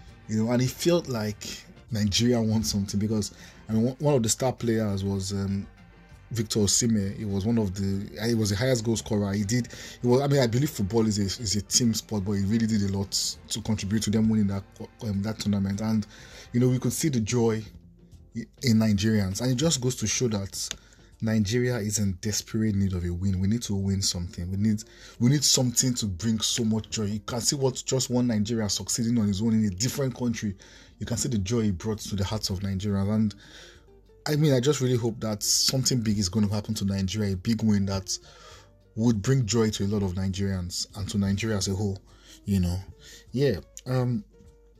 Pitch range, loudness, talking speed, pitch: 100-115 Hz, -26 LUFS, 220 wpm, 110 Hz